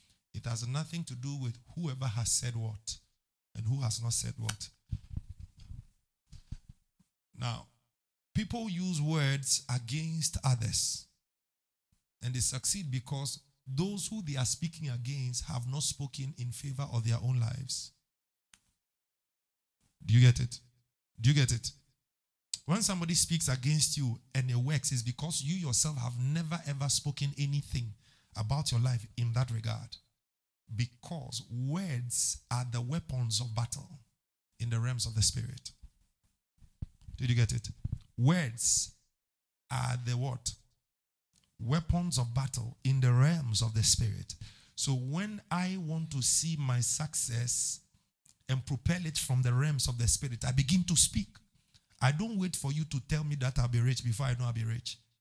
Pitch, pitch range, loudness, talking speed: 125 Hz, 115-140 Hz, -32 LUFS, 155 wpm